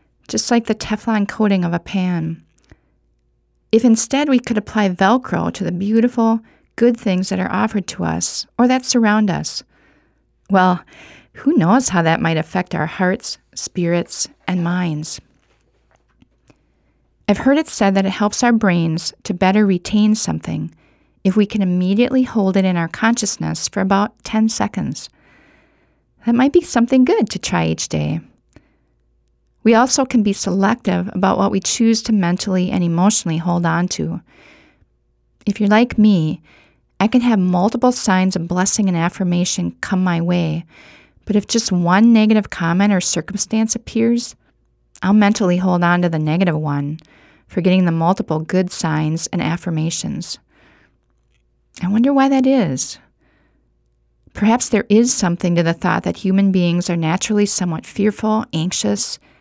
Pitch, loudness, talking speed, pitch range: 190 Hz, -17 LUFS, 155 wpm, 170-220 Hz